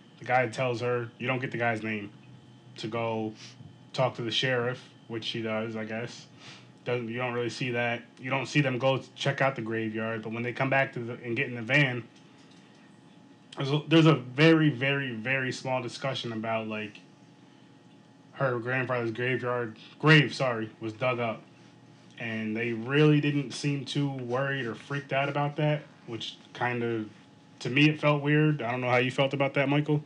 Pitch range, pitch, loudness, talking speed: 115-140 Hz, 125 Hz, -28 LUFS, 190 wpm